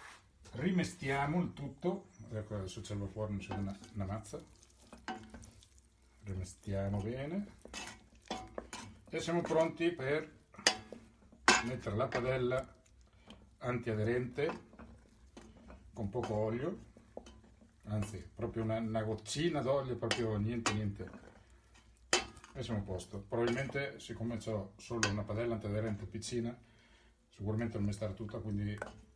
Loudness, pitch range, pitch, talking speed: -38 LUFS, 105-125 Hz, 110 Hz, 105 wpm